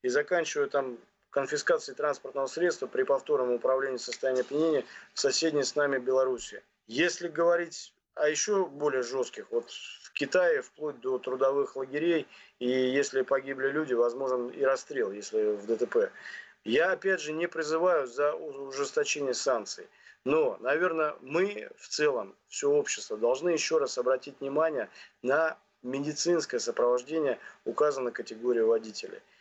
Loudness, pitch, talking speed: -29 LUFS, 165 Hz, 135 wpm